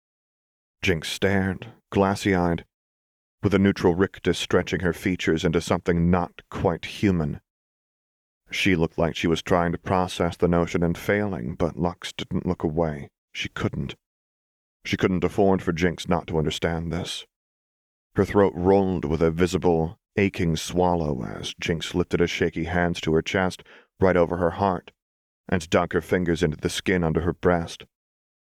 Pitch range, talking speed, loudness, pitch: 85-95 Hz, 155 wpm, -24 LUFS, 90 Hz